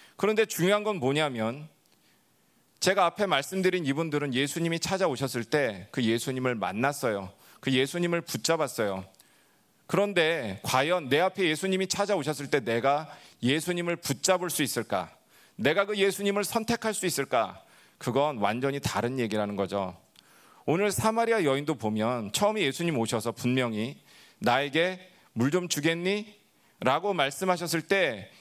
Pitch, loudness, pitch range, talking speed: 155 Hz, -28 LUFS, 125-185 Hz, 315 characters per minute